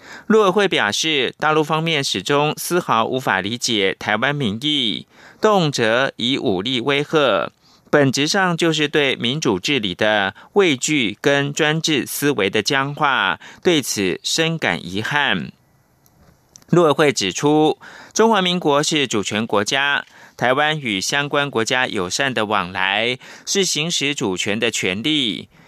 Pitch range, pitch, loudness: 115-160 Hz, 145 Hz, -18 LUFS